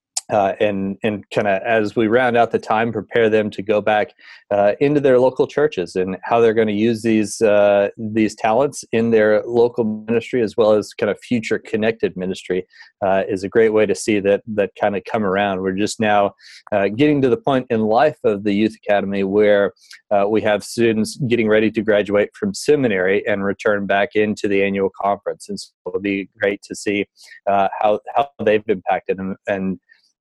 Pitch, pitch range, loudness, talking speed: 105 Hz, 100-115 Hz, -18 LUFS, 205 wpm